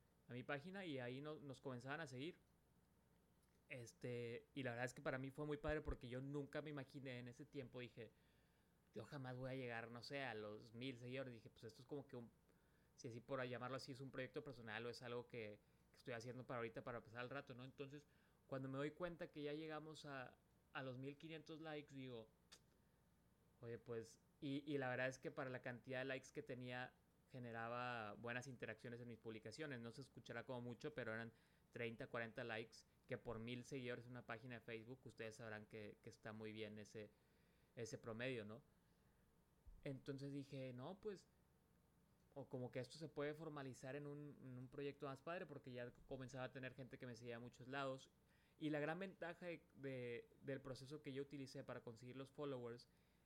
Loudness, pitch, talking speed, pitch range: -53 LUFS, 130 Hz, 205 wpm, 120-145 Hz